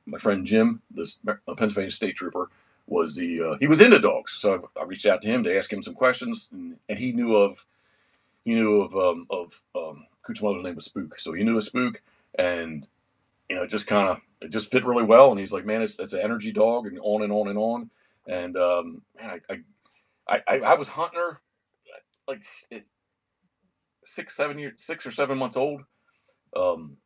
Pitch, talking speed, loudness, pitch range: 120 Hz, 210 wpm, -24 LUFS, 105-170 Hz